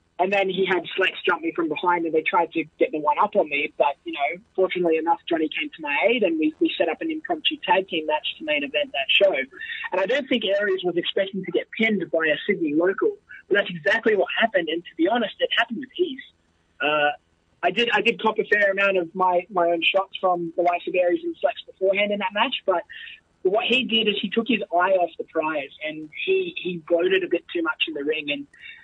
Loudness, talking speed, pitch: -23 LUFS, 250 wpm, 200 Hz